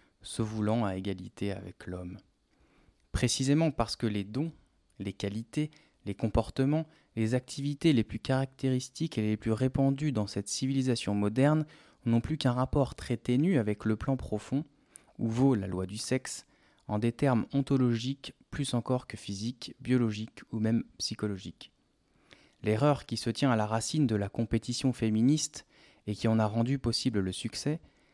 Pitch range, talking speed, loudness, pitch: 105-135 Hz, 160 wpm, -31 LUFS, 115 Hz